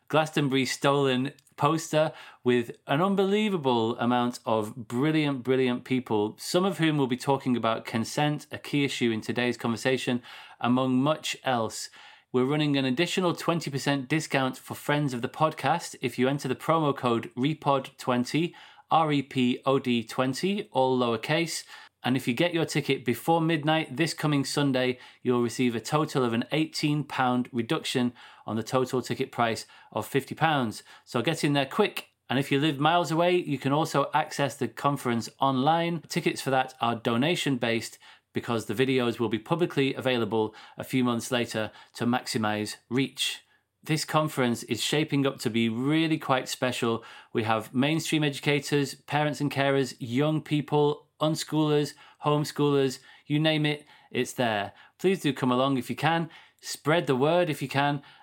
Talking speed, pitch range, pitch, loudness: 165 wpm, 125-150 Hz, 135 Hz, -27 LUFS